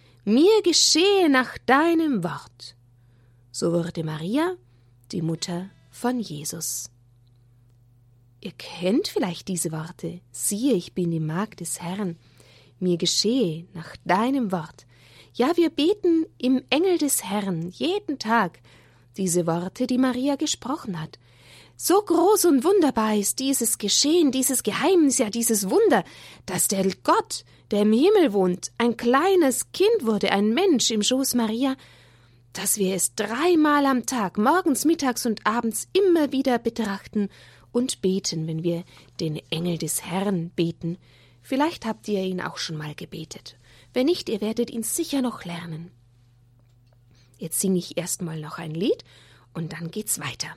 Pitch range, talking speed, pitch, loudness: 160-260 Hz, 145 wpm, 195 Hz, -23 LUFS